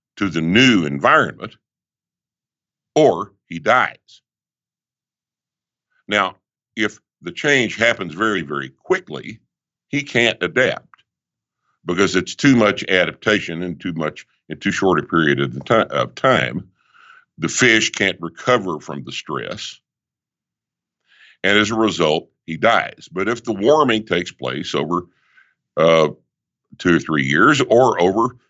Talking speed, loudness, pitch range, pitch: 135 wpm, -18 LUFS, 80-115 Hz, 100 Hz